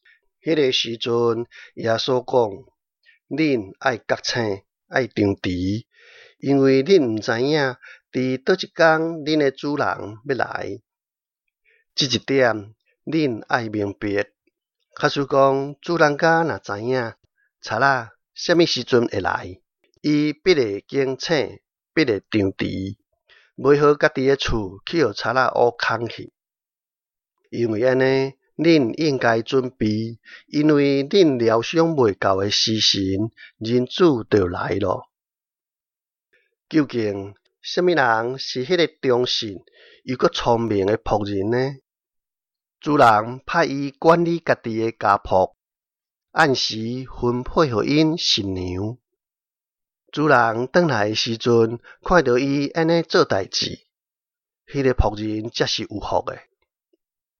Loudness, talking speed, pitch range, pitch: -20 LUFS, 170 characters per minute, 110-155 Hz, 130 Hz